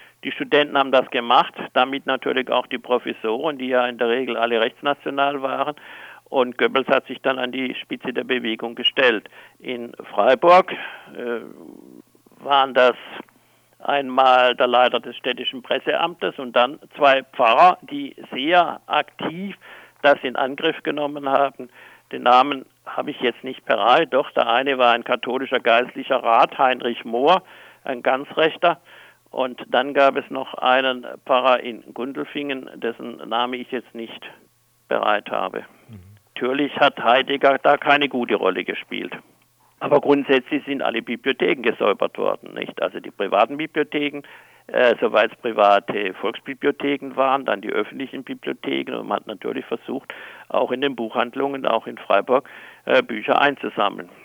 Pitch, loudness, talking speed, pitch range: 130 Hz, -20 LUFS, 145 wpm, 125-140 Hz